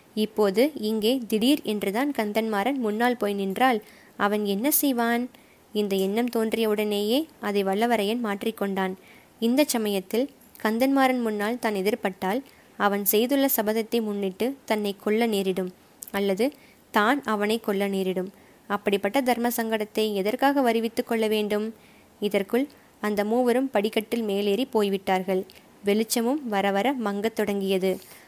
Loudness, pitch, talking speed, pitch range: -25 LUFS, 215 Hz, 110 wpm, 205-240 Hz